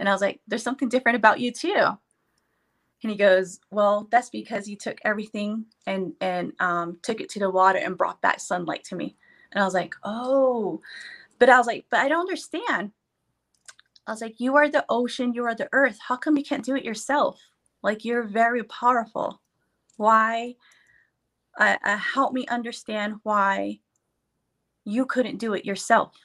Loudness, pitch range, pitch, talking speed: -24 LUFS, 205-250 Hz, 230 Hz, 180 wpm